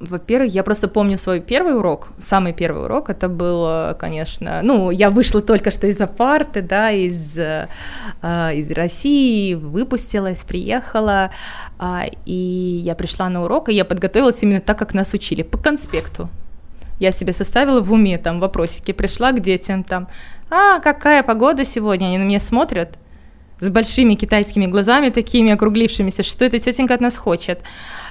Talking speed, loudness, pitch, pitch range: 160 wpm, -17 LUFS, 200 Hz, 180-230 Hz